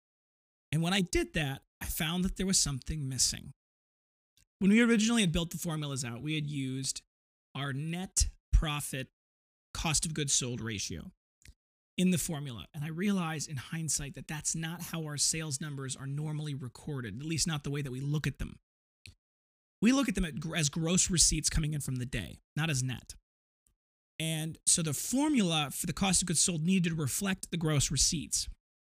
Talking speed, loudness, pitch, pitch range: 185 wpm, -31 LUFS, 150 Hz, 135-170 Hz